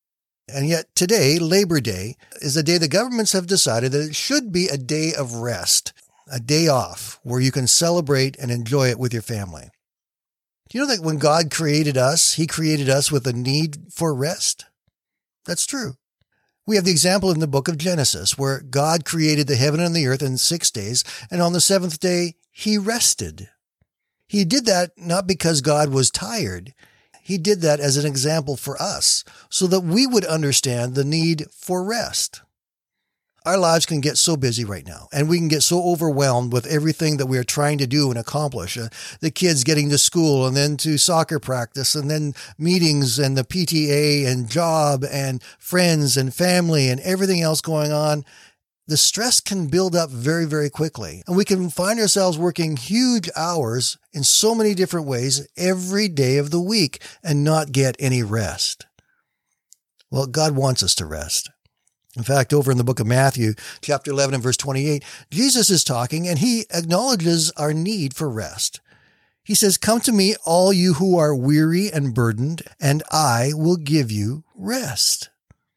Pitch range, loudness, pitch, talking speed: 135-175 Hz, -19 LUFS, 150 Hz, 185 wpm